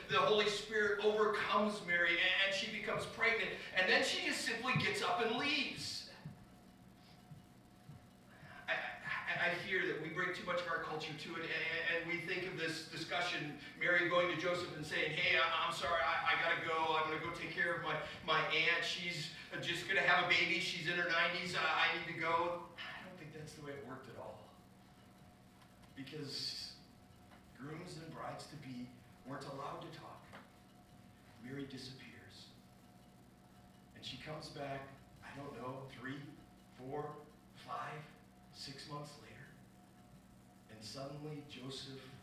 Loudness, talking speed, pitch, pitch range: -37 LUFS, 155 wpm, 155 Hz, 125-175 Hz